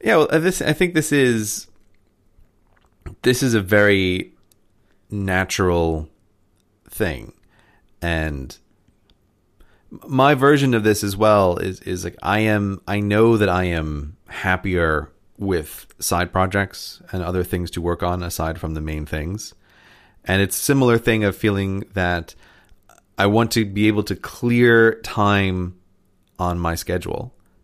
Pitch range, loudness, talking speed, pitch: 90-110 Hz, -20 LUFS, 140 wpm, 95 Hz